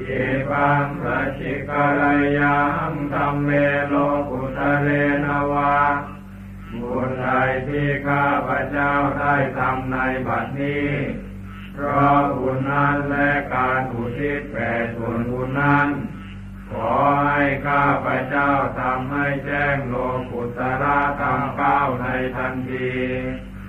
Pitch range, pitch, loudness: 130-145 Hz, 140 Hz, -21 LUFS